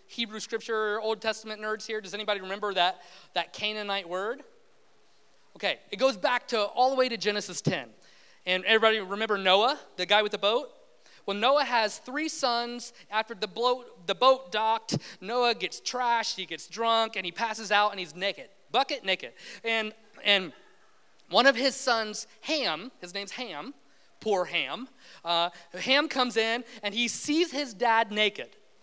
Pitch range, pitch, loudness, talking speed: 200-245 Hz, 220 Hz, -28 LUFS, 165 wpm